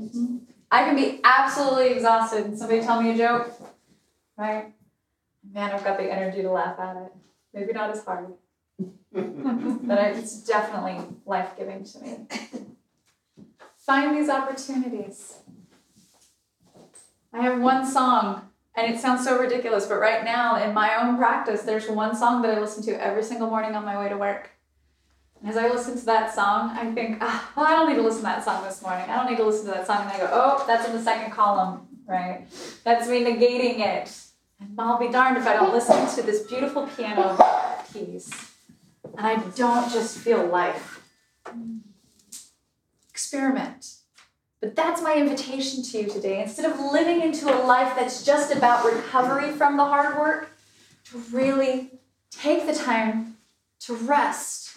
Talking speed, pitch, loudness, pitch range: 170 wpm, 230 Hz, -23 LUFS, 210-255 Hz